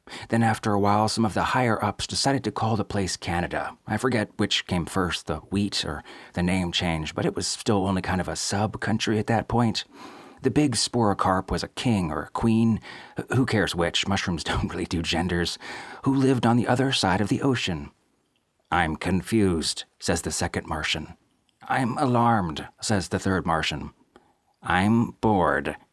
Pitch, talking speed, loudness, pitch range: 100 Hz, 185 wpm, -25 LUFS, 85-115 Hz